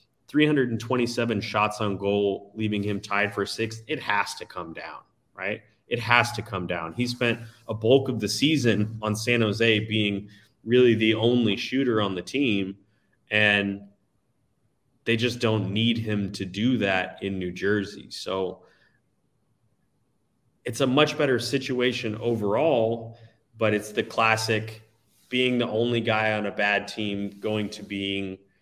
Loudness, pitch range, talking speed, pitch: -25 LUFS, 100-120 Hz, 150 wpm, 110 Hz